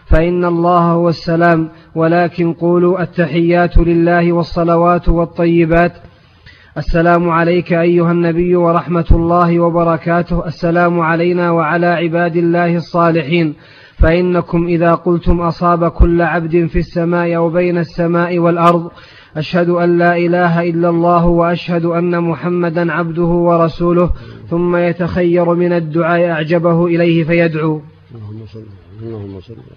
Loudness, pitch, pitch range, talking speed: -13 LUFS, 170 Hz, 170-175 Hz, 105 wpm